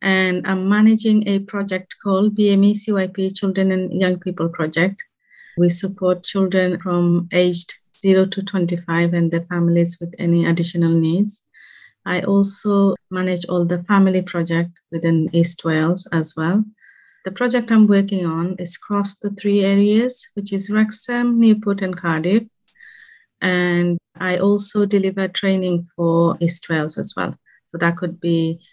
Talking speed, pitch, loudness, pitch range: 145 wpm, 185 Hz, -18 LUFS, 170-200 Hz